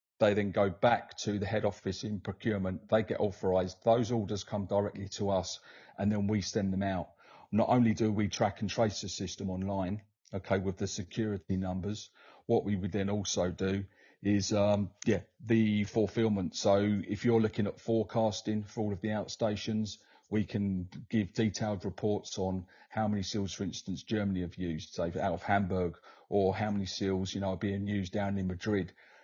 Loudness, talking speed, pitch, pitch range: -33 LUFS, 190 wpm, 100 Hz, 95-105 Hz